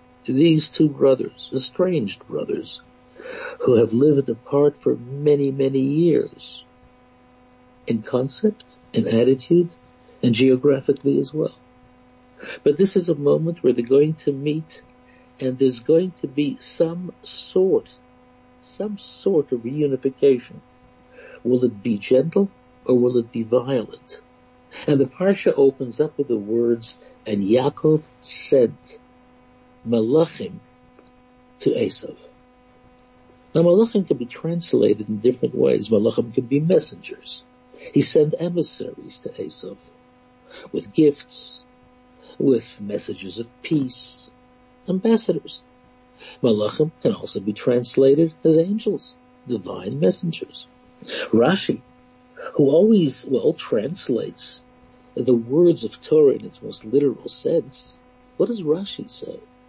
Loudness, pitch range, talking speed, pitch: -21 LUFS, 125-205 Hz, 115 wpm, 145 Hz